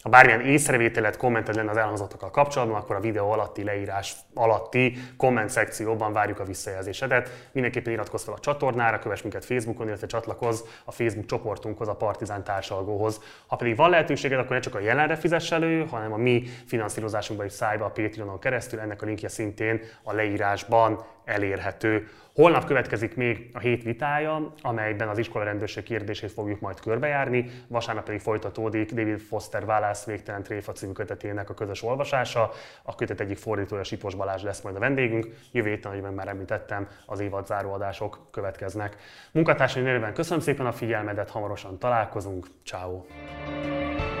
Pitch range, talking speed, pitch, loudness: 105-125 Hz, 155 wpm, 110 Hz, -27 LUFS